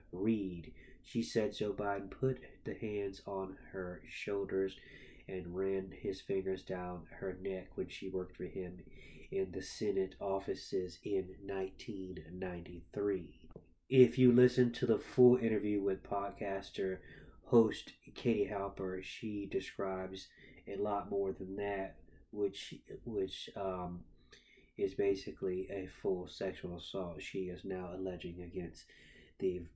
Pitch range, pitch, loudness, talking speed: 90-100 Hz, 95 Hz, -37 LUFS, 130 wpm